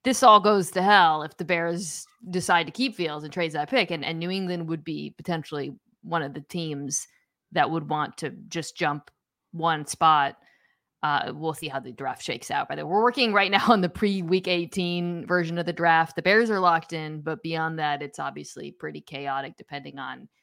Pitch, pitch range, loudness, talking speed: 170 Hz, 155-185 Hz, -25 LUFS, 210 wpm